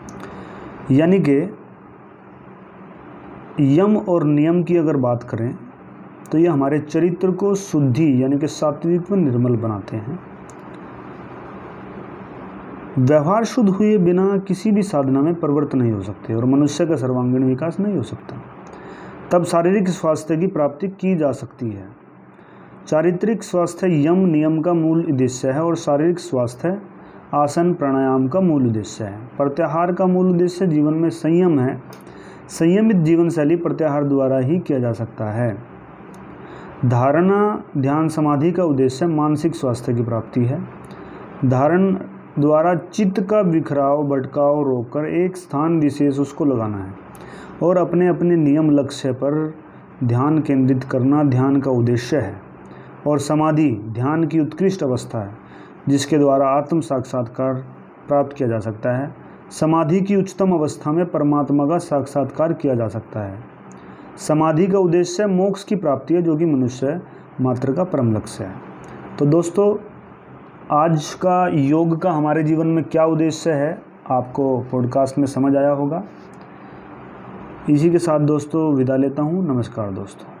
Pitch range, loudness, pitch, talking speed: 130-170 Hz, -18 LUFS, 150 Hz, 145 wpm